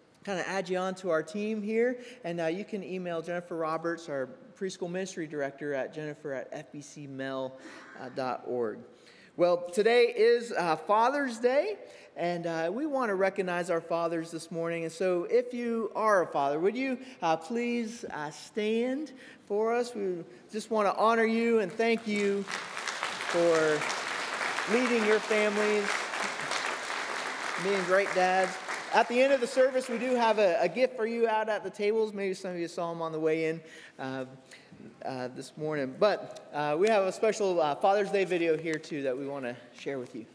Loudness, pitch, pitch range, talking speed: -30 LUFS, 190 Hz, 165-220 Hz, 185 wpm